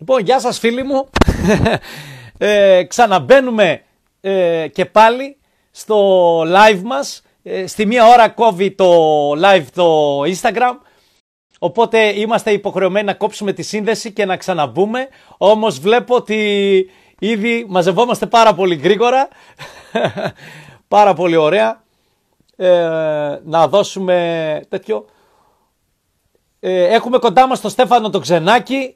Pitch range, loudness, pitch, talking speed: 180-230 Hz, -14 LUFS, 205 Hz, 100 wpm